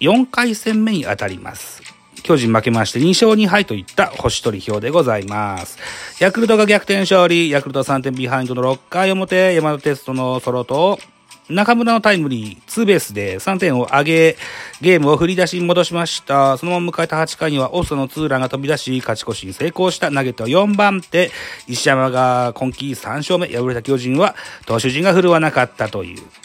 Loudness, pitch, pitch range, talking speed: -16 LUFS, 150 Hz, 125-180 Hz, 370 characters per minute